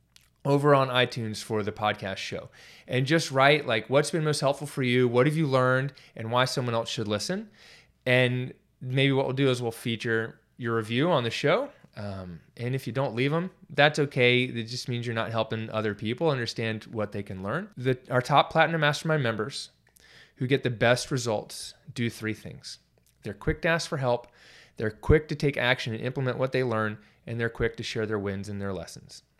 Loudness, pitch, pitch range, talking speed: -27 LUFS, 125 Hz, 110-140 Hz, 210 wpm